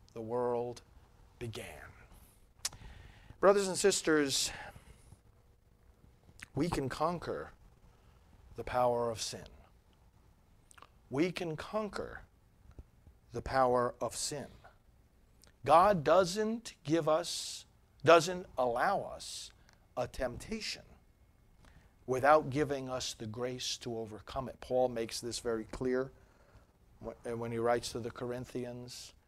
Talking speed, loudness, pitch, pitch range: 100 wpm, -33 LUFS, 120 Hz, 100-140 Hz